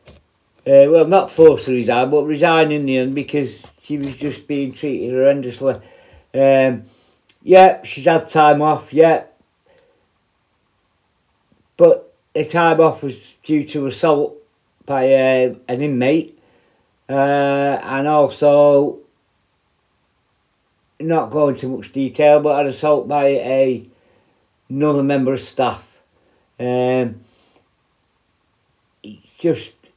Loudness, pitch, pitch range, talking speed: -16 LUFS, 140 Hz, 130-150 Hz, 115 wpm